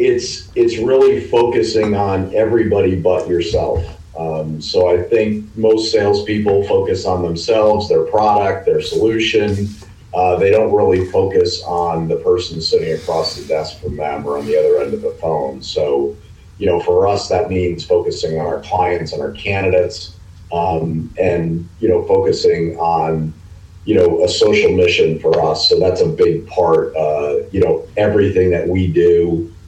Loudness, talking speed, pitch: -15 LUFS, 165 wpm, 110 Hz